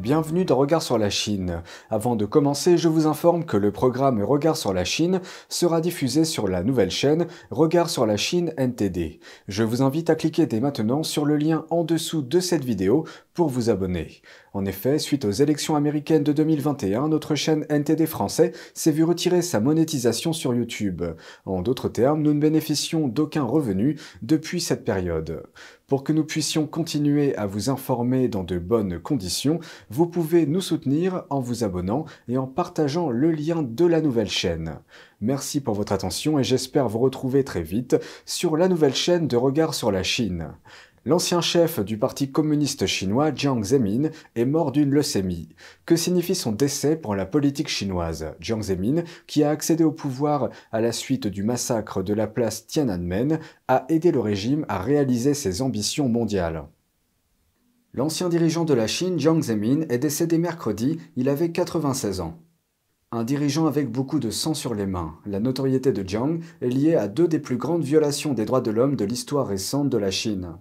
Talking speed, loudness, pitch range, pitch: 185 wpm, -23 LUFS, 110-160 Hz, 140 Hz